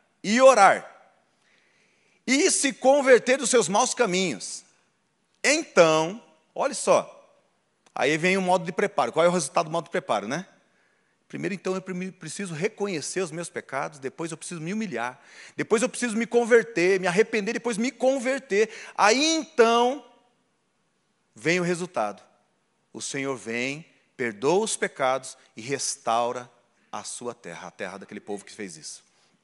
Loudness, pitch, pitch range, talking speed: -24 LUFS, 185 Hz, 150-240 Hz, 150 wpm